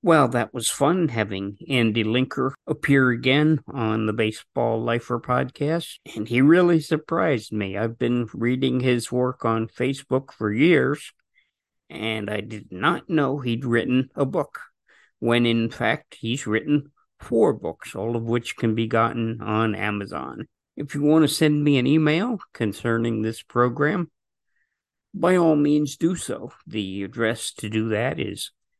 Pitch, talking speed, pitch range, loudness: 120 Hz, 155 wpm, 115-145 Hz, -23 LUFS